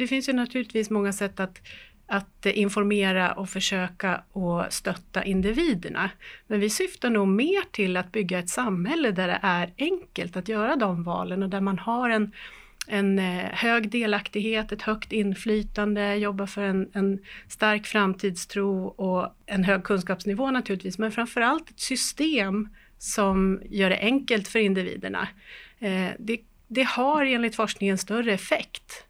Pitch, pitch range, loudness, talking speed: 205 Hz, 195-230 Hz, -26 LUFS, 145 wpm